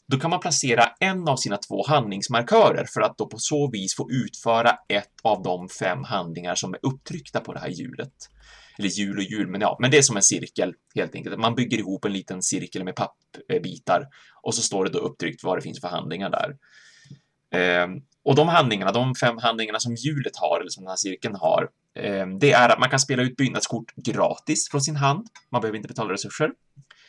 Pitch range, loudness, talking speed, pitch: 100-145 Hz, -23 LUFS, 210 wpm, 120 Hz